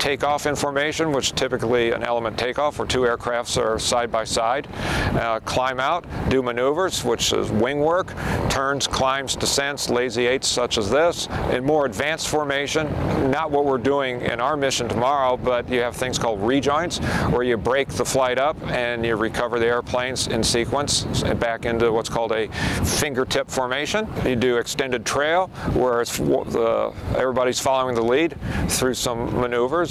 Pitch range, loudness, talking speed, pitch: 120-140 Hz, -22 LUFS, 170 wpm, 125 Hz